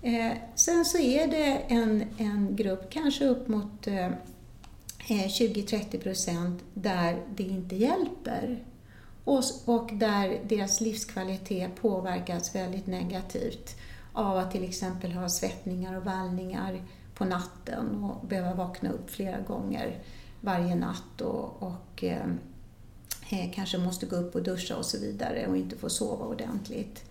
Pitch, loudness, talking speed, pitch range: 195 Hz, -31 LUFS, 135 wpm, 180-230 Hz